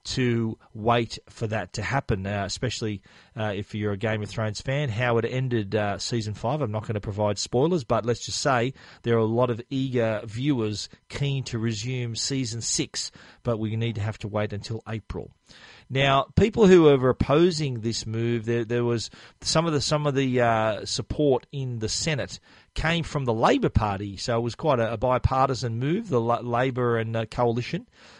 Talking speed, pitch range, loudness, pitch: 200 wpm, 110-130 Hz, -25 LUFS, 120 Hz